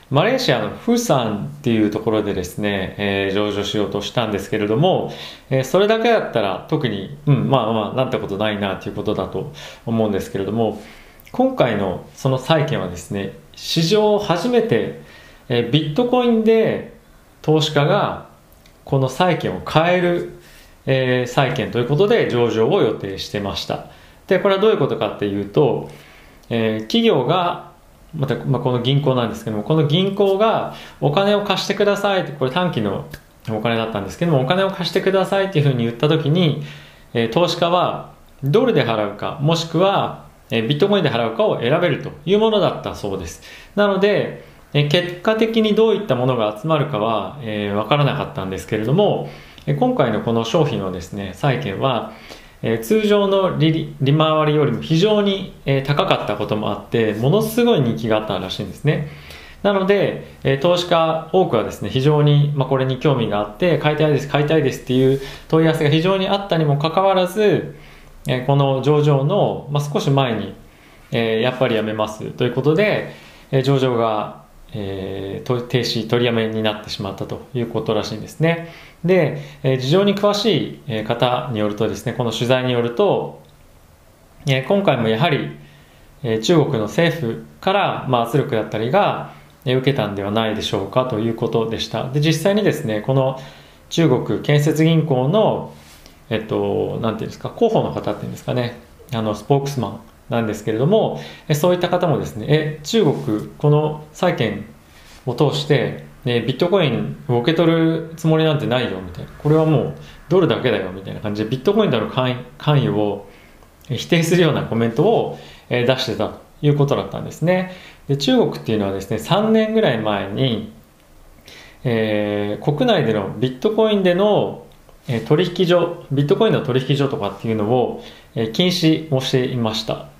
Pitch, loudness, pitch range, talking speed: 130 Hz, -19 LUFS, 105-160 Hz, 345 characters per minute